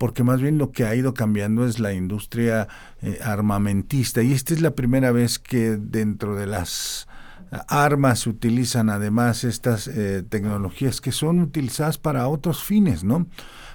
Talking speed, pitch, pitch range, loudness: 160 wpm, 120 Hz, 105-135 Hz, -22 LUFS